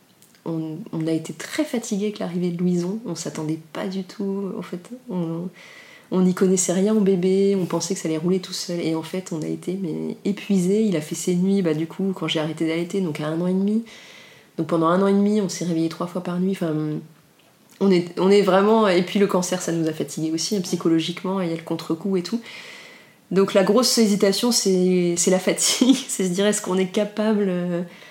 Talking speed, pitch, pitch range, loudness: 235 wpm, 185 Hz, 165-200 Hz, -22 LUFS